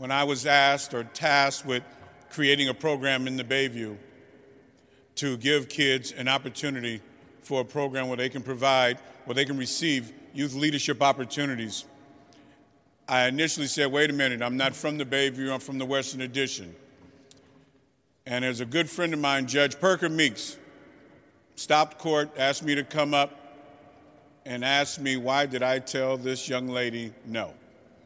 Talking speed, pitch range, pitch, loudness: 165 wpm, 130-145 Hz, 135 Hz, -26 LUFS